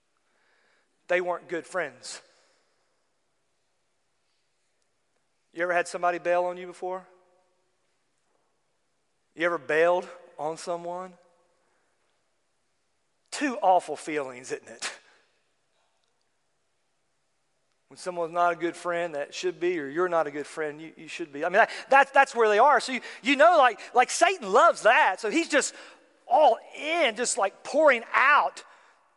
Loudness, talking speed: -24 LUFS, 140 wpm